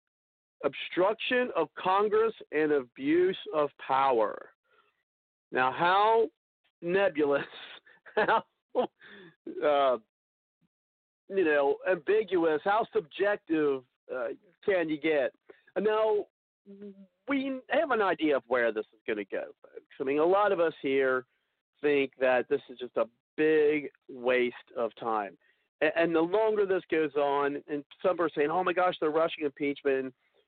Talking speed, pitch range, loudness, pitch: 135 wpm, 135-215 Hz, -29 LUFS, 160 Hz